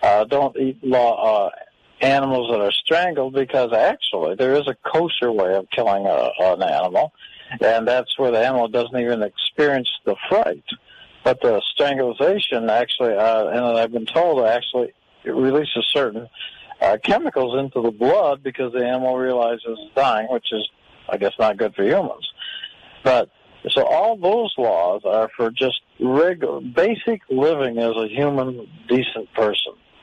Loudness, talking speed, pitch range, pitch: -20 LUFS, 160 wpm, 115-135 Hz, 125 Hz